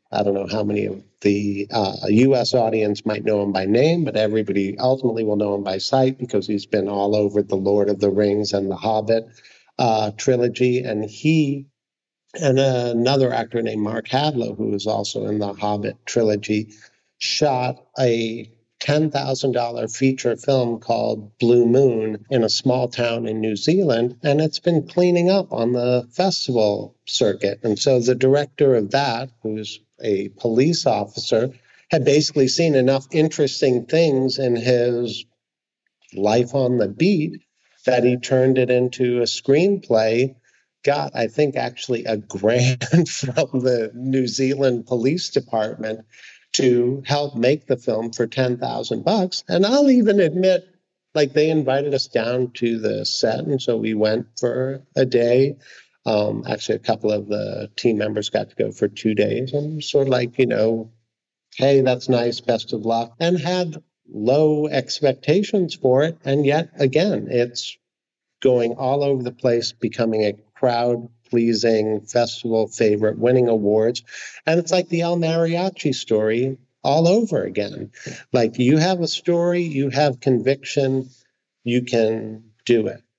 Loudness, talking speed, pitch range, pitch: -20 LUFS, 155 wpm, 110-140 Hz, 125 Hz